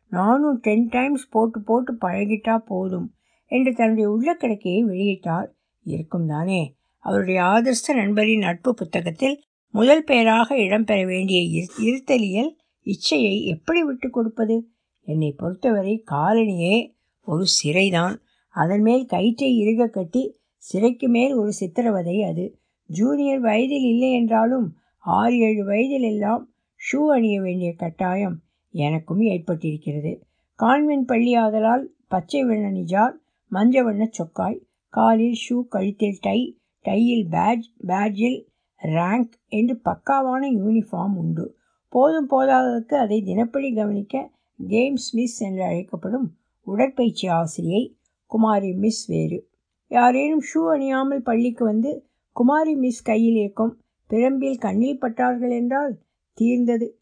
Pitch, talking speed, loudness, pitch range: 225 Hz, 110 wpm, -21 LUFS, 195-250 Hz